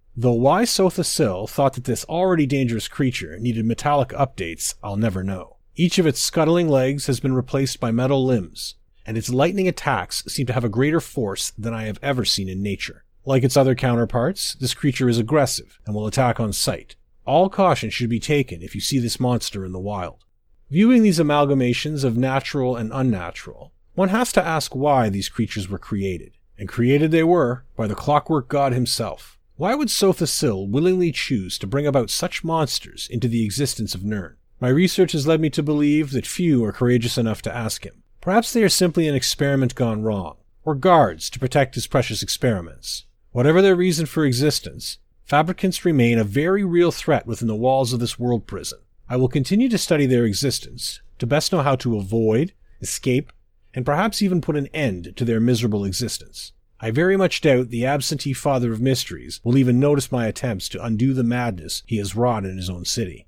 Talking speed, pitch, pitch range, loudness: 195 wpm, 125 Hz, 110-150 Hz, -21 LUFS